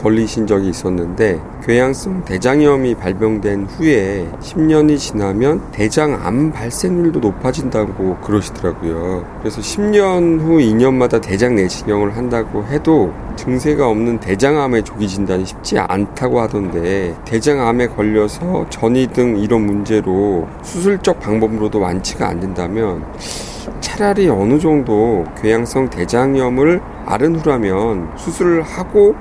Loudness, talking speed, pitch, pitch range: -15 LUFS, 290 characters per minute, 115 Hz, 100-145 Hz